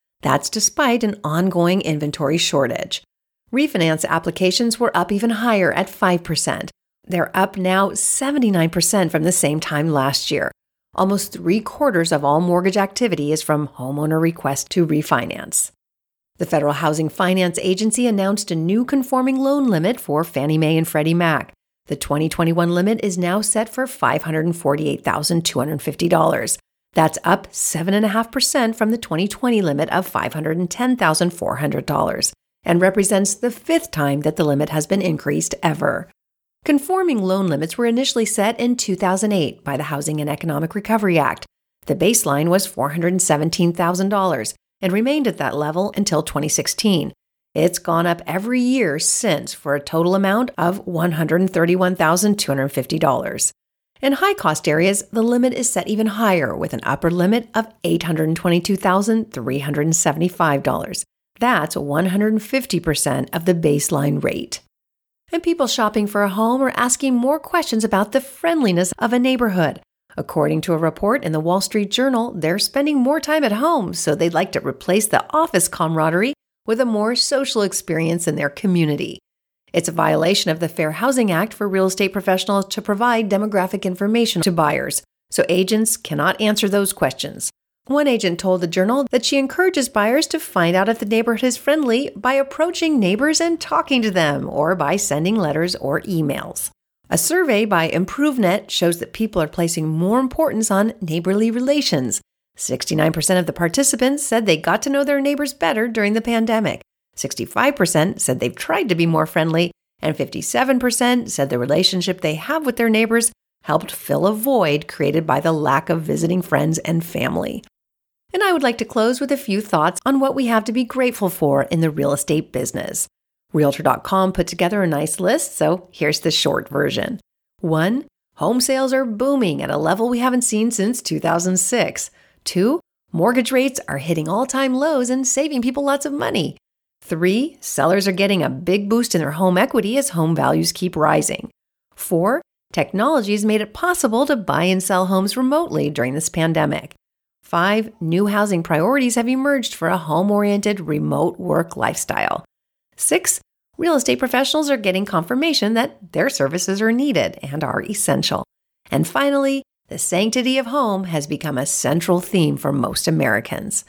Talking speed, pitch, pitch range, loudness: 160 wpm, 190 Hz, 165-240 Hz, -19 LUFS